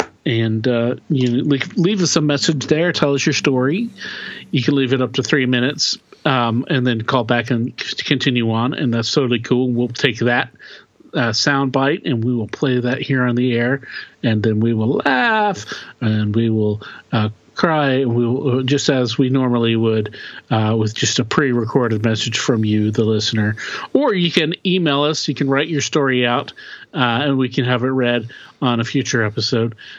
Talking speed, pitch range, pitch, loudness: 195 wpm, 115-140 Hz, 125 Hz, -18 LUFS